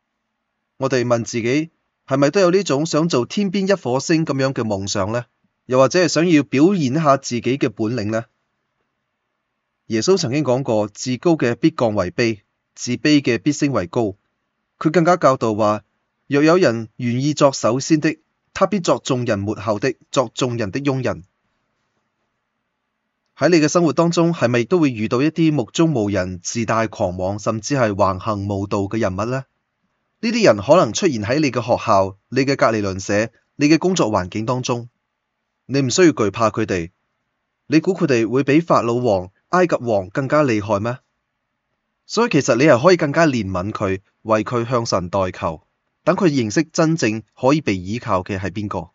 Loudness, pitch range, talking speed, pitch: -18 LUFS, 110-150 Hz, 255 characters per minute, 125 Hz